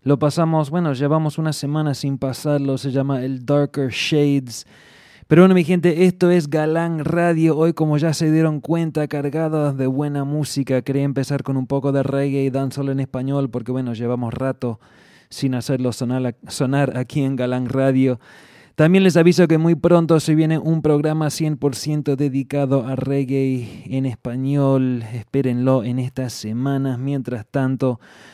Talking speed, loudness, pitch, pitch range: 160 wpm, -19 LUFS, 140 Hz, 130-155 Hz